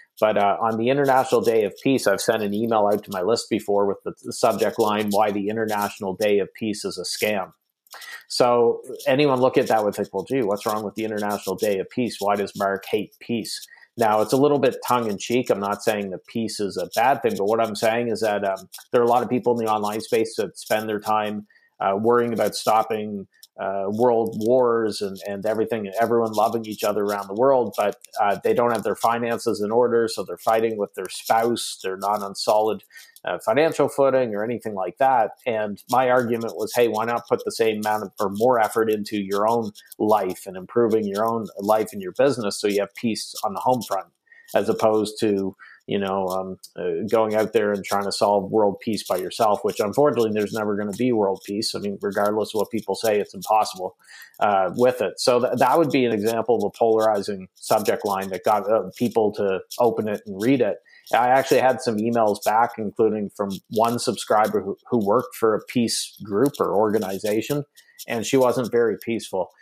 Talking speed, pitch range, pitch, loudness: 215 wpm, 100-120 Hz, 110 Hz, -22 LUFS